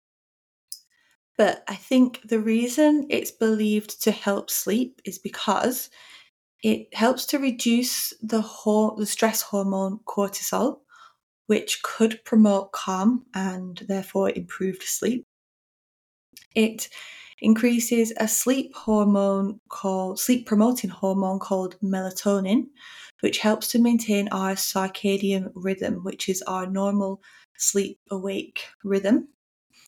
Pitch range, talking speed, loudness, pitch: 195-235 Hz, 105 wpm, -24 LUFS, 210 Hz